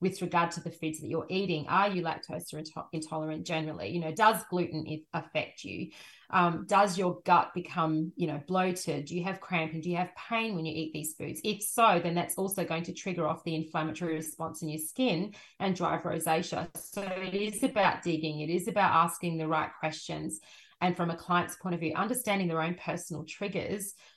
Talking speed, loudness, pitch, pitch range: 205 wpm, -31 LUFS, 170 Hz, 160-185 Hz